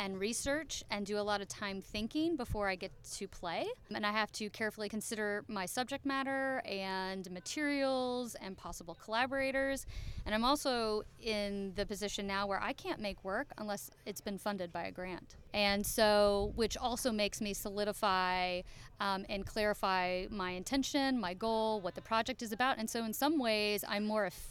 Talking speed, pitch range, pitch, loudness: 180 wpm, 195-240 Hz, 210 Hz, -36 LUFS